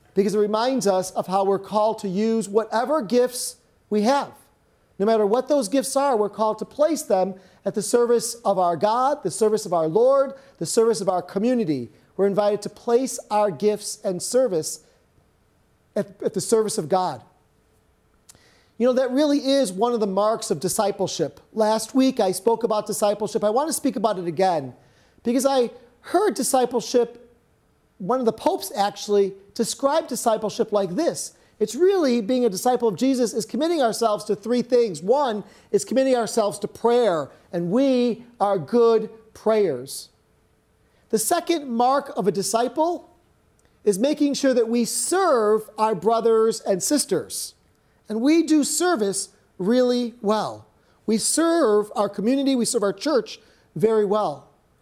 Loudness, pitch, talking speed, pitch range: -22 LUFS, 225 Hz, 160 wpm, 205-255 Hz